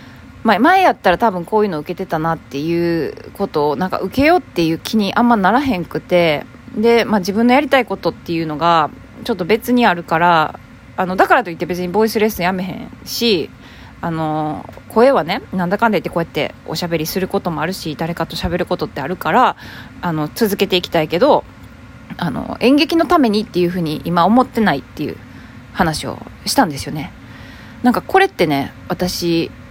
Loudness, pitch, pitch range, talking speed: -16 LUFS, 180 Hz, 165-230 Hz, 400 characters per minute